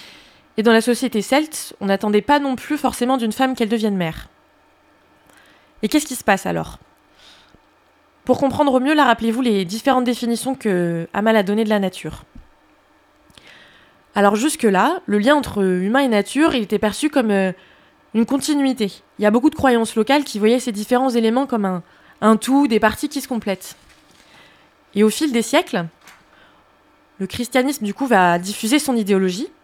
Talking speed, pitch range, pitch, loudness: 175 wpm, 205-265 Hz, 230 Hz, -18 LUFS